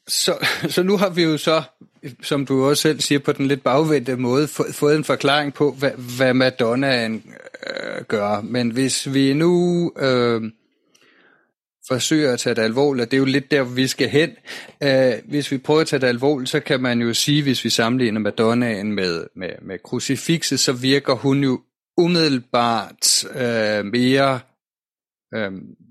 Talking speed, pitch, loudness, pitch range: 175 wpm, 135 Hz, -19 LUFS, 125-150 Hz